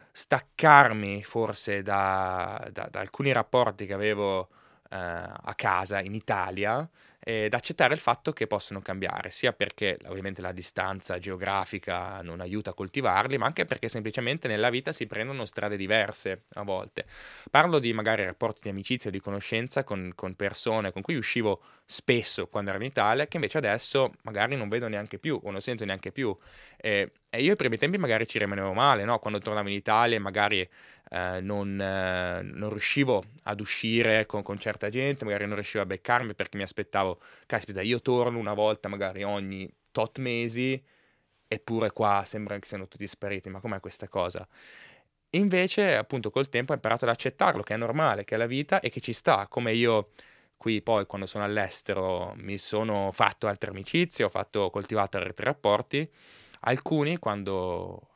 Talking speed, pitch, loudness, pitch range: 175 wpm, 105 Hz, -28 LUFS, 100-115 Hz